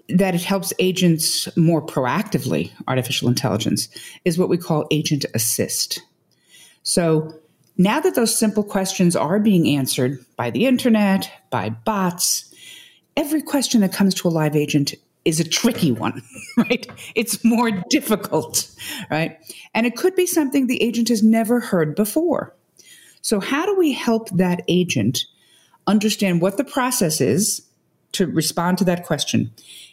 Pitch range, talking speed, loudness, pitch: 155-225 Hz, 145 wpm, -20 LUFS, 185 Hz